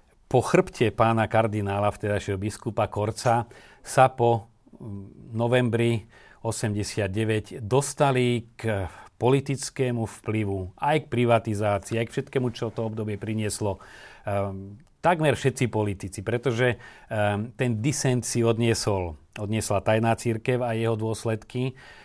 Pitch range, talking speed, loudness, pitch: 105-125 Hz, 110 wpm, -26 LUFS, 115 Hz